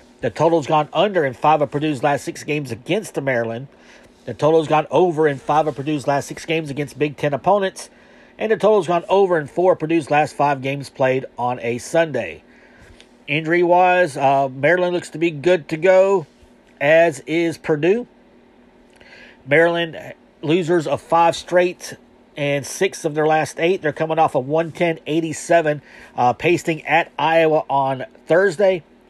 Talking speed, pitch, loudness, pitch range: 165 wpm, 155 Hz, -18 LUFS, 145-170 Hz